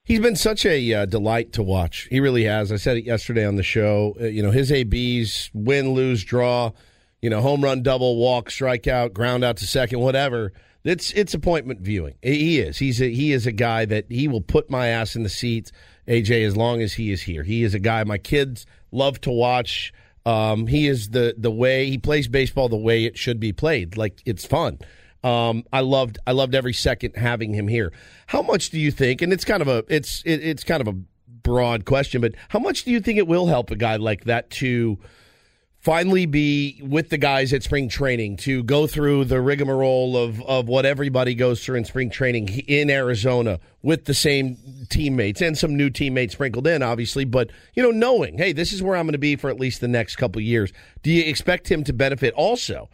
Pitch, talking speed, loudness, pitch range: 125 Hz, 225 wpm, -21 LUFS, 115-140 Hz